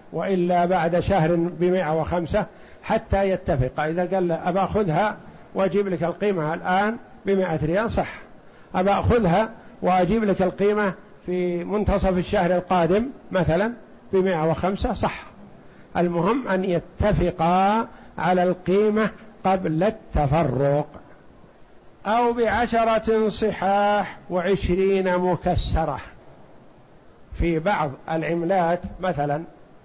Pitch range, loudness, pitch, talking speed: 175-205 Hz, -23 LUFS, 185 Hz, 95 wpm